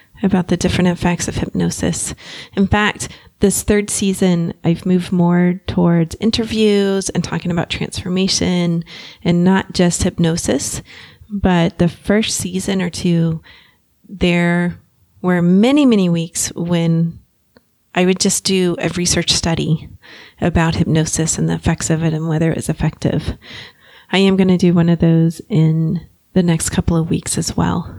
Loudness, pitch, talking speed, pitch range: -16 LUFS, 175 Hz, 150 wpm, 165-190 Hz